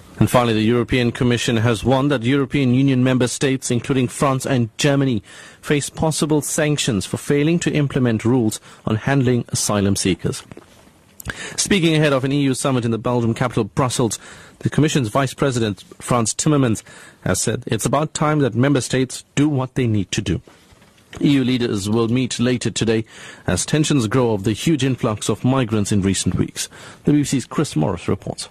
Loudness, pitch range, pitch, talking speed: -19 LUFS, 115-140 Hz, 125 Hz, 175 wpm